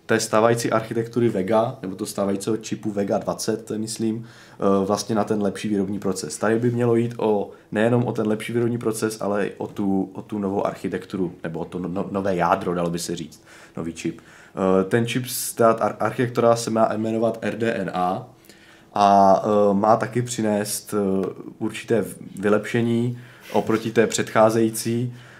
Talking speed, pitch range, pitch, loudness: 155 wpm, 100-115 Hz, 110 Hz, -22 LUFS